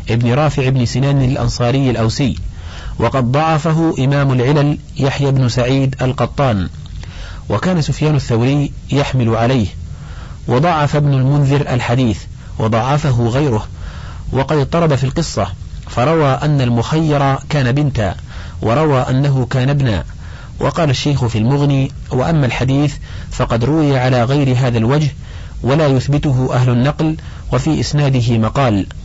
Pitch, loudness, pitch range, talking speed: 130 Hz, -15 LUFS, 115-145 Hz, 120 wpm